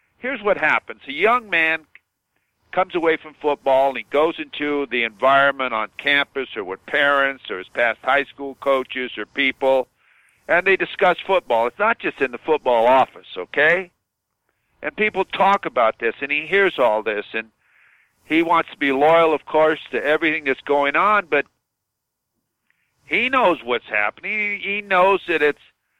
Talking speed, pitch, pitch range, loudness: 170 wpm, 150 Hz, 135-175 Hz, -19 LUFS